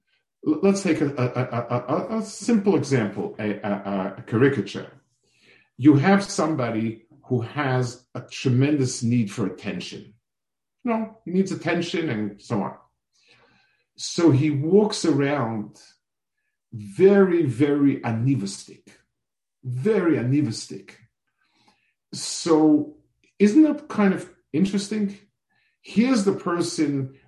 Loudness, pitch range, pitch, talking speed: -23 LUFS, 120-195 Hz, 150 Hz, 110 wpm